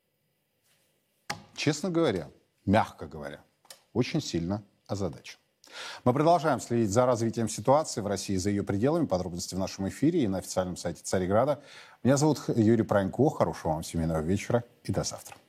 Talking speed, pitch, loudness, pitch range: 150 wpm, 110 Hz, -28 LUFS, 95-125 Hz